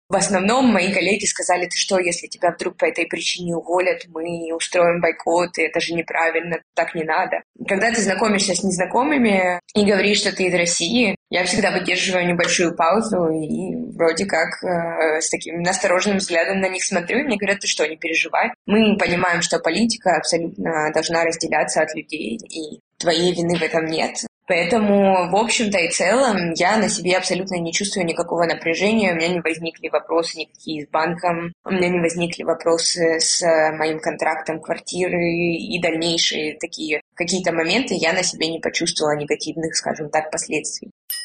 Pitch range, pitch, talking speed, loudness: 165-190 Hz, 175 Hz, 170 wpm, -19 LUFS